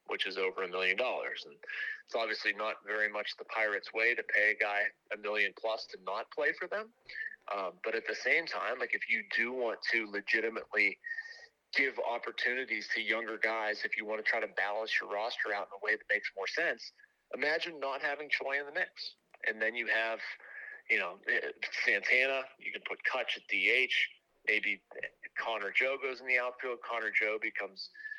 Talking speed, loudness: 195 wpm, -33 LUFS